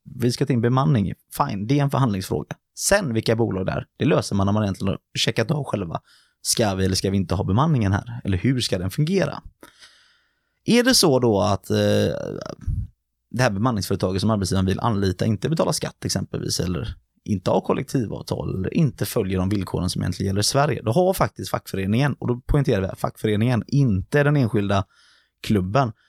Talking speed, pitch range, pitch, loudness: 195 wpm, 100-140 Hz, 115 Hz, -22 LUFS